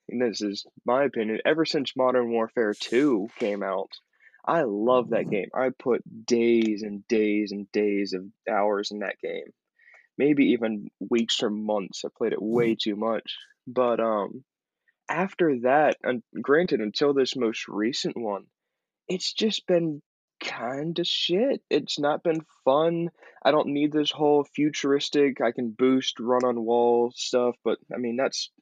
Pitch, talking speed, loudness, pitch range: 125 Hz, 160 wpm, -25 LUFS, 110-150 Hz